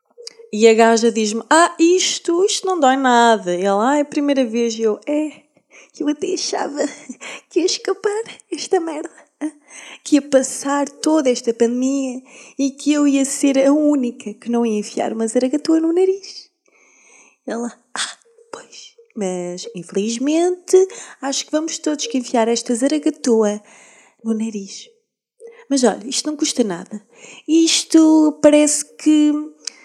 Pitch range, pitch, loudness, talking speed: 235-330 Hz, 285 Hz, -17 LUFS, 150 wpm